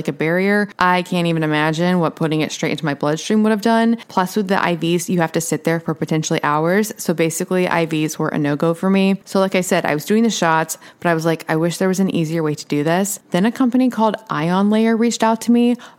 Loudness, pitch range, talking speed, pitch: -18 LUFS, 160-205 Hz, 265 wpm, 180 Hz